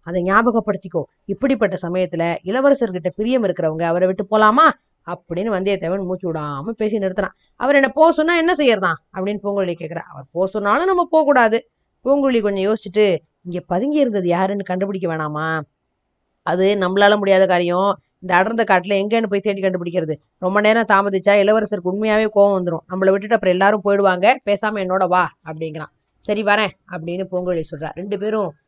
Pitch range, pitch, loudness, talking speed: 180-215 Hz, 195 Hz, -18 LUFS, 150 wpm